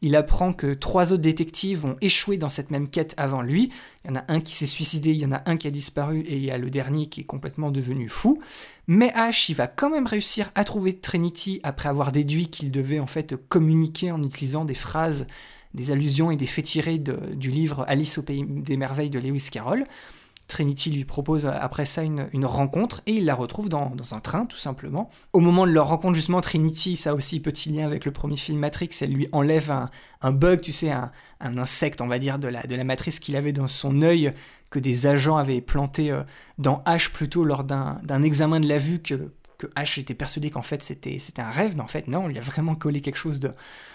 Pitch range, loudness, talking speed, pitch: 140-165 Hz, -24 LUFS, 240 wpm, 150 Hz